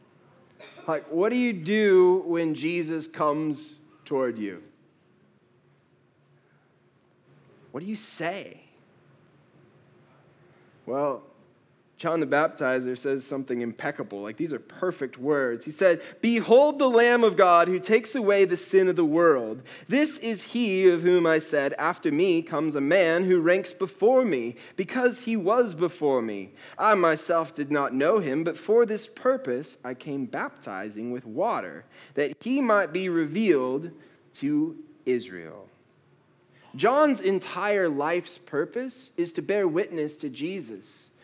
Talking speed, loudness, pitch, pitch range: 135 wpm, -25 LUFS, 175 Hz, 145-225 Hz